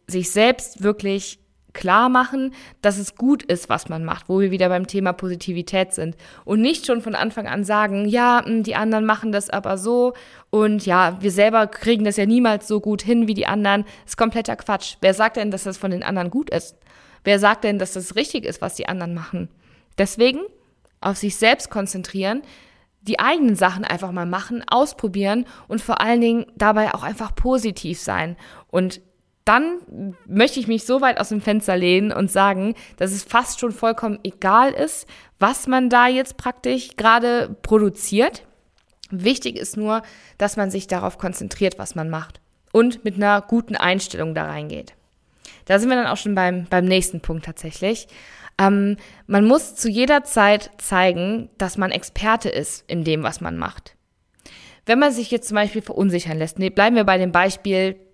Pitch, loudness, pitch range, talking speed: 205 Hz, -20 LUFS, 185-230 Hz, 185 wpm